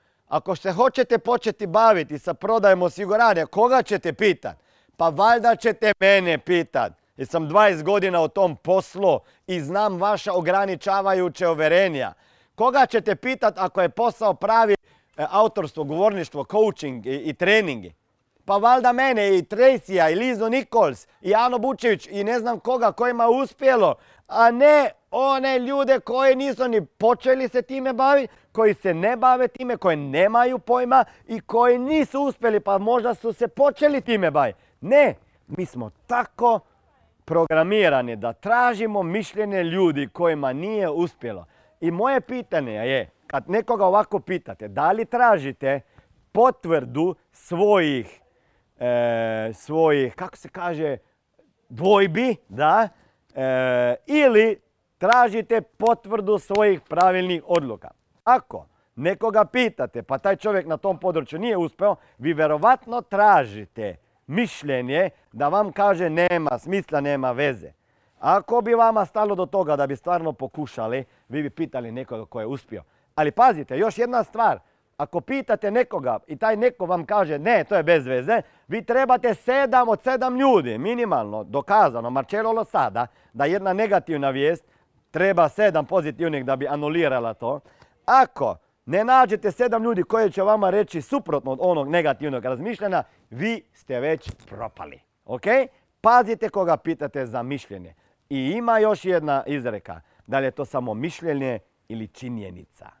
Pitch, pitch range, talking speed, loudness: 195 Hz, 150-230 Hz, 140 wpm, -21 LUFS